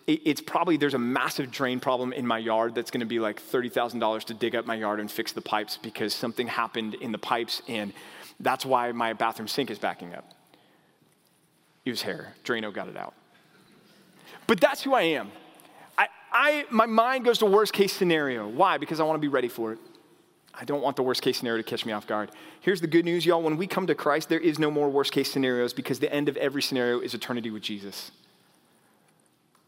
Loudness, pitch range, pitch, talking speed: -27 LUFS, 115-170 Hz, 135 Hz, 220 wpm